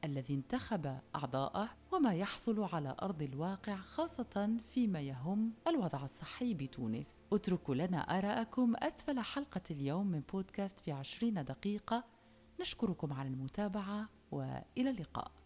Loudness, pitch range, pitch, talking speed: -39 LUFS, 145-230 Hz, 195 Hz, 115 wpm